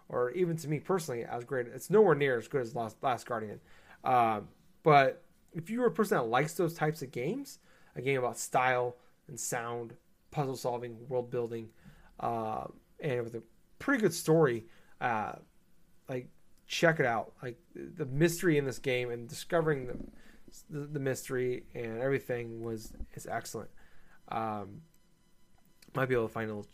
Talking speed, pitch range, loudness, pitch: 165 wpm, 120-165 Hz, -32 LUFS, 130 Hz